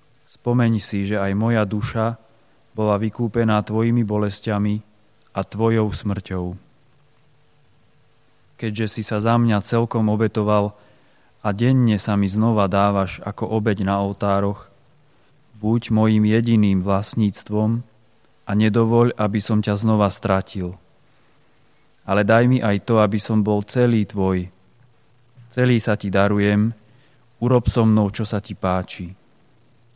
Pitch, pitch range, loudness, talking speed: 110 Hz, 100-115 Hz, -20 LUFS, 125 wpm